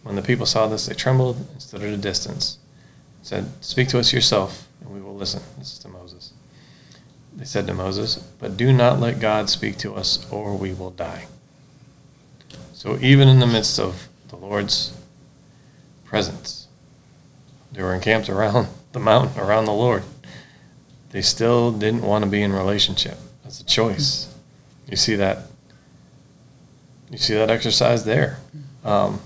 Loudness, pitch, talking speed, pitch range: -20 LUFS, 120 Hz, 165 wpm, 105-135 Hz